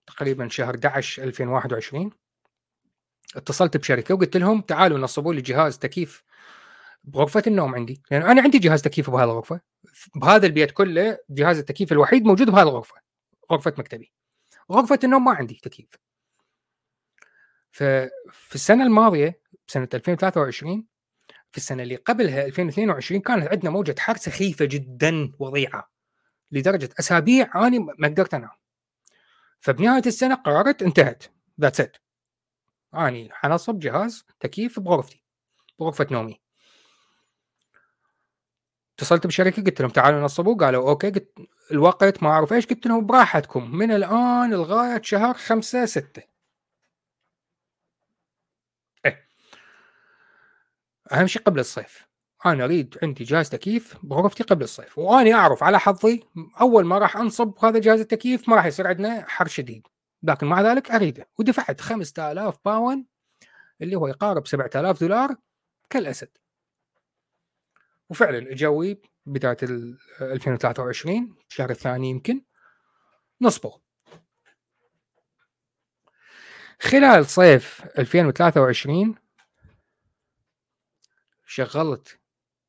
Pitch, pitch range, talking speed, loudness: 175 Hz, 140-220 Hz, 115 wpm, -20 LUFS